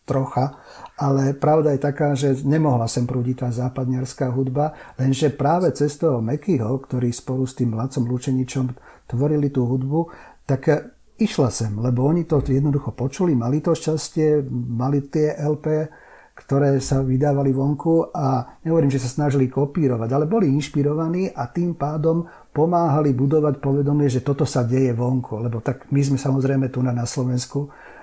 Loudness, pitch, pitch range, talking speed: -21 LUFS, 140 Hz, 130-150 Hz, 155 wpm